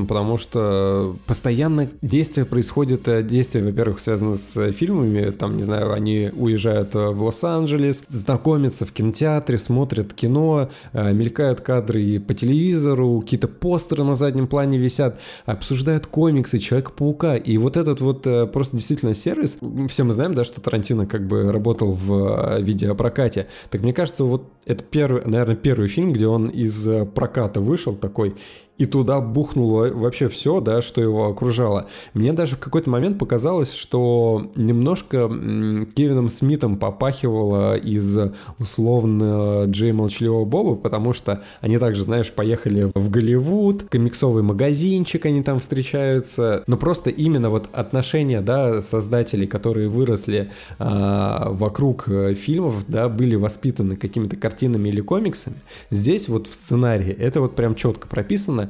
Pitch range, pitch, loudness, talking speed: 105-135 Hz, 120 Hz, -20 LUFS, 140 wpm